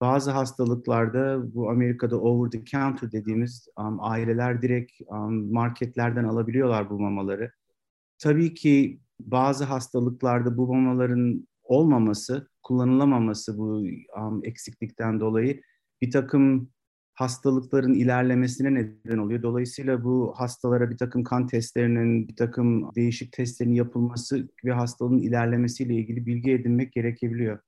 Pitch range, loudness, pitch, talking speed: 115-130 Hz, -25 LUFS, 120 Hz, 110 wpm